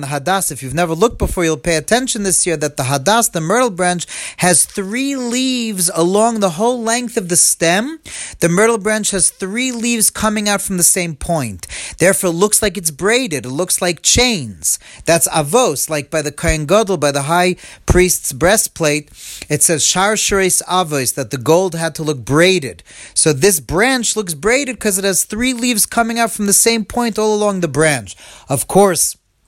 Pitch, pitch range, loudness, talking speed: 185 Hz, 160-220 Hz, -14 LUFS, 190 wpm